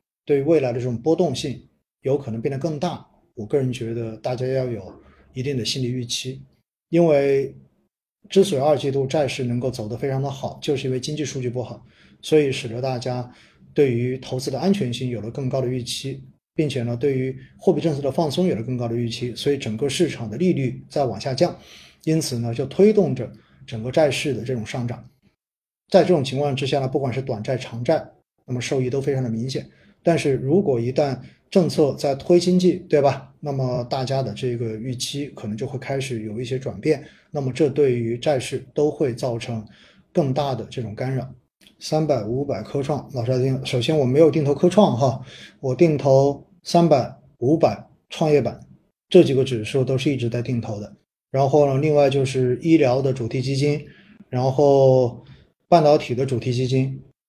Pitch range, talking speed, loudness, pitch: 125-150 Hz, 285 characters per minute, -22 LUFS, 135 Hz